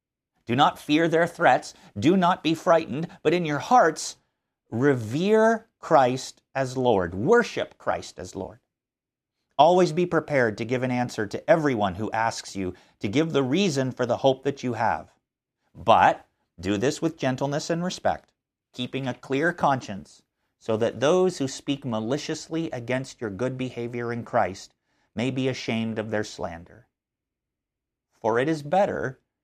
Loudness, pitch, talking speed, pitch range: -24 LUFS, 135 Hz, 155 wpm, 120-160 Hz